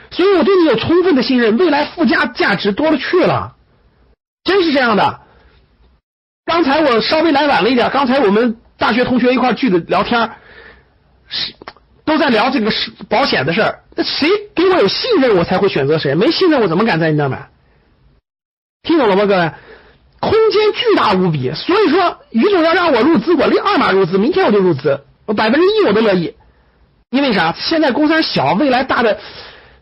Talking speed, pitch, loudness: 280 characters per minute, 275 Hz, -13 LUFS